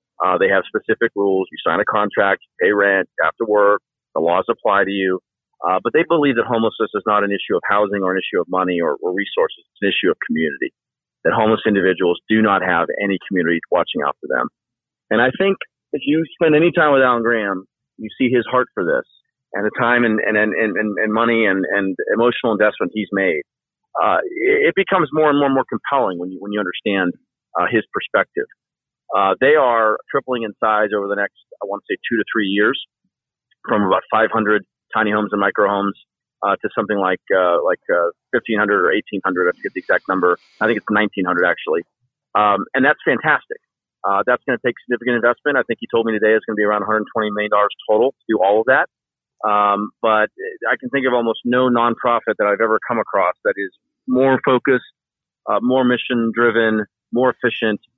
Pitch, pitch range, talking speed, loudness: 110 Hz, 100-125 Hz, 210 wpm, -18 LUFS